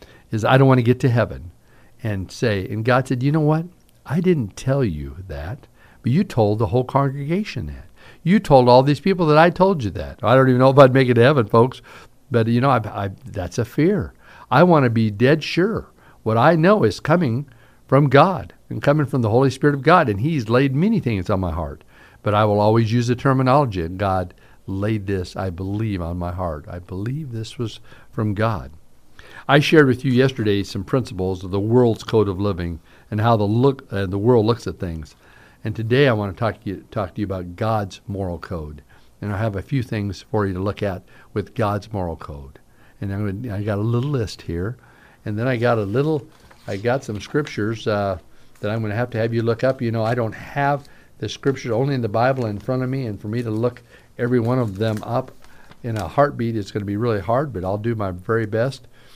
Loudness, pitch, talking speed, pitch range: -20 LUFS, 115 Hz, 235 wpm, 100-130 Hz